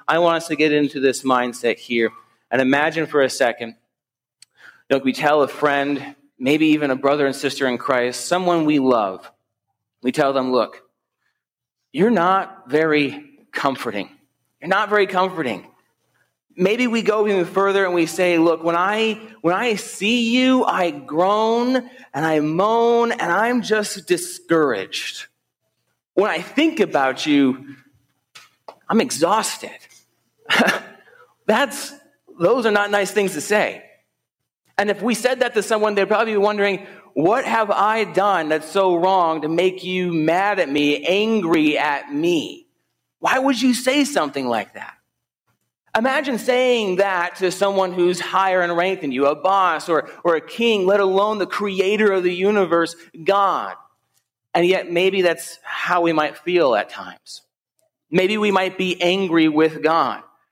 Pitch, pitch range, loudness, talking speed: 185 Hz, 155-215 Hz, -19 LUFS, 155 wpm